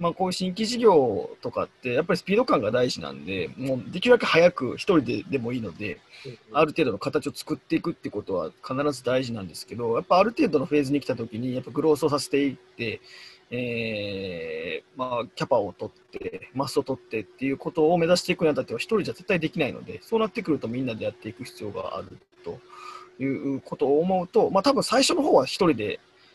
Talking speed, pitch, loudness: 440 characters per minute, 155 Hz, -25 LUFS